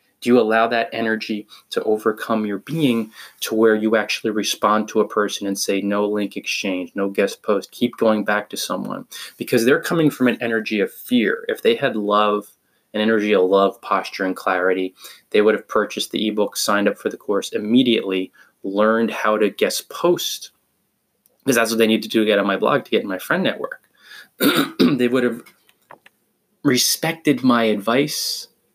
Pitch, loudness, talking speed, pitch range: 110 Hz, -19 LUFS, 185 wpm, 105-120 Hz